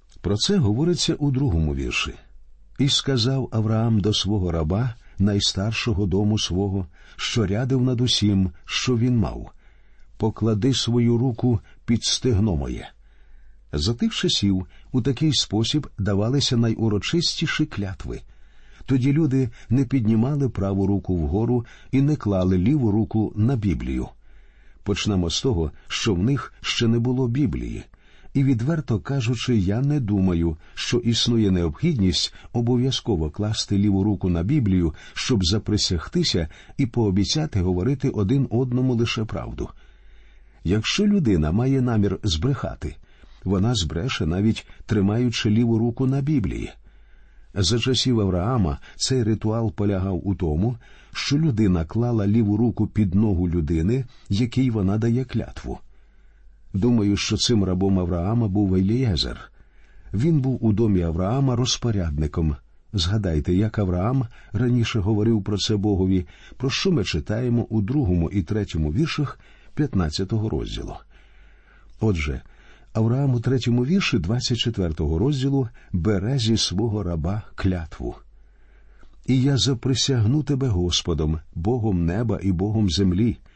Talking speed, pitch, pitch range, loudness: 125 wpm, 110 Hz, 95-125 Hz, -22 LUFS